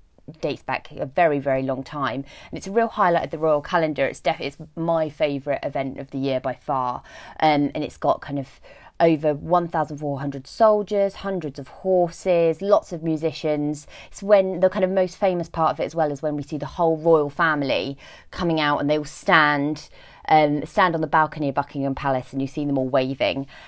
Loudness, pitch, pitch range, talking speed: -22 LUFS, 150 Hz, 140-170 Hz, 215 wpm